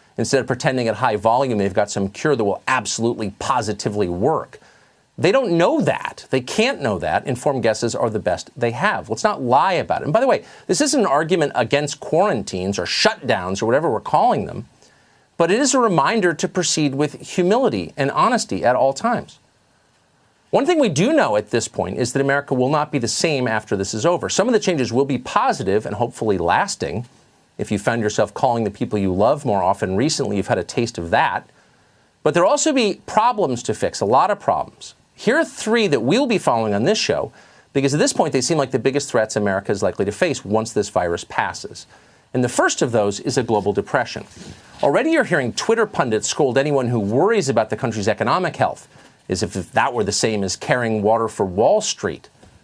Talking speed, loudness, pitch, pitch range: 215 wpm, -19 LUFS, 130 Hz, 110-155 Hz